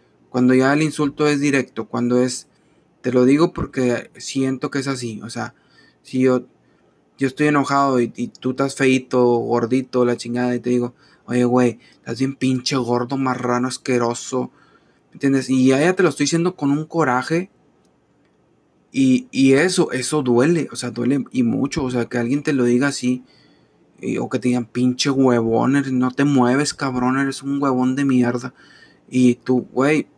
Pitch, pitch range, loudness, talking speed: 130 Hz, 125-140 Hz, -19 LUFS, 180 wpm